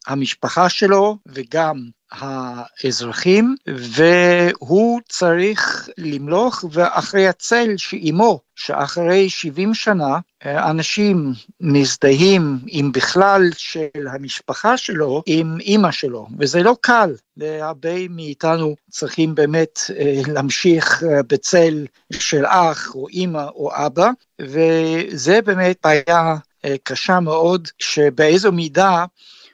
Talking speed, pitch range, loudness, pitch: 90 wpm, 145-185 Hz, -17 LUFS, 165 Hz